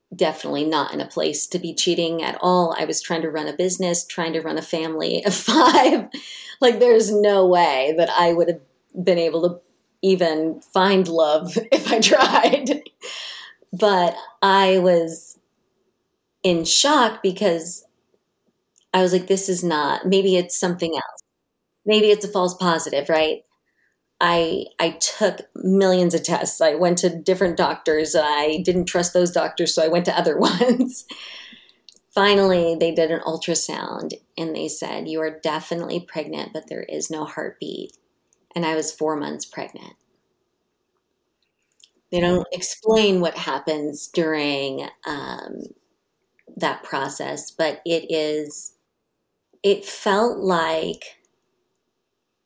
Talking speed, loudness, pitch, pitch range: 140 wpm, -20 LUFS, 175 Hz, 165-195 Hz